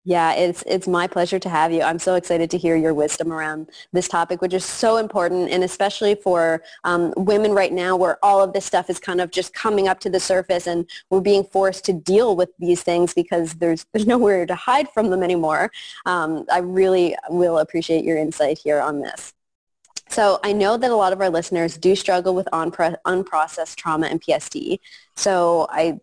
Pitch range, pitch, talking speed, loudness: 165-190 Hz, 180 Hz, 210 wpm, -20 LUFS